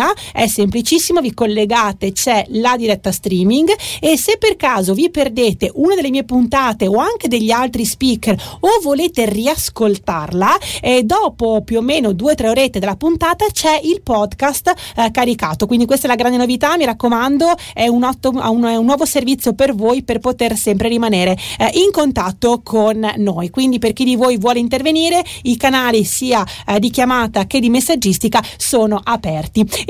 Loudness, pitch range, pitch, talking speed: -14 LUFS, 215-280 Hz, 240 Hz, 175 wpm